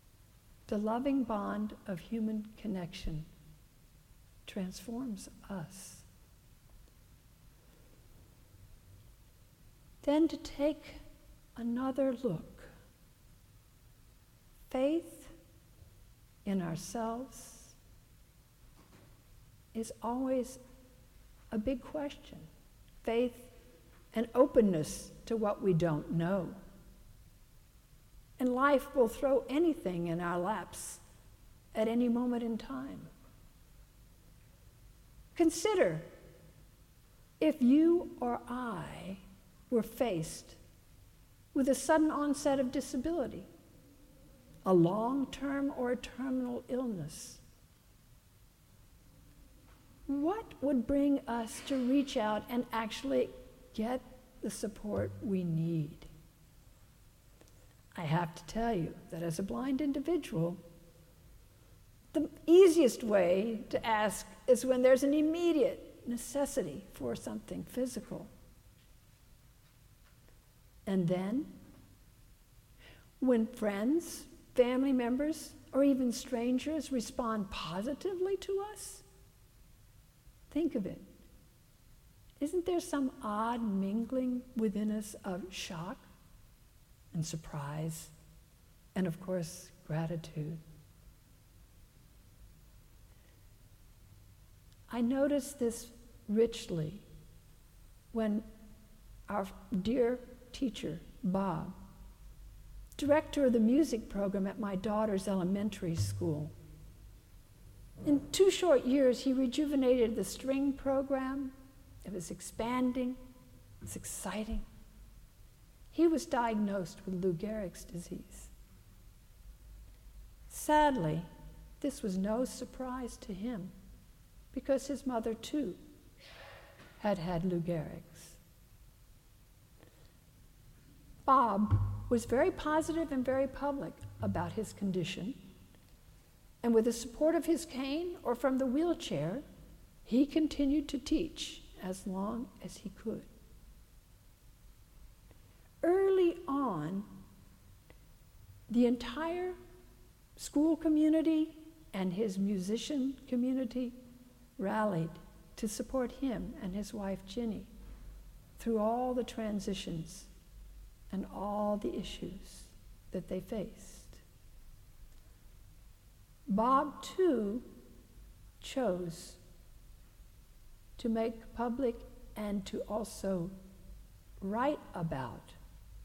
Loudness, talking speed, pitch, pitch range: -34 LUFS, 85 wpm, 220 Hz, 160-265 Hz